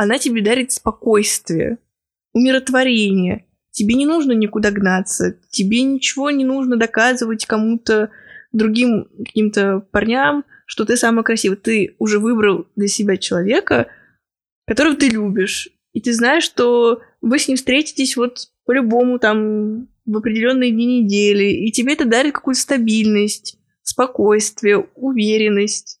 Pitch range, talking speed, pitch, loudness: 210-250 Hz, 125 wpm, 230 Hz, -16 LUFS